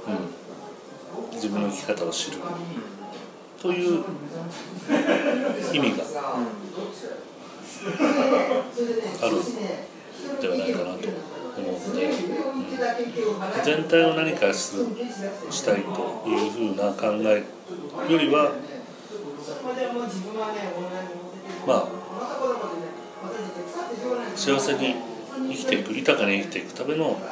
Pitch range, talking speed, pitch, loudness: 155-250 Hz, 165 characters per minute, 200 Hz, -26 LUFS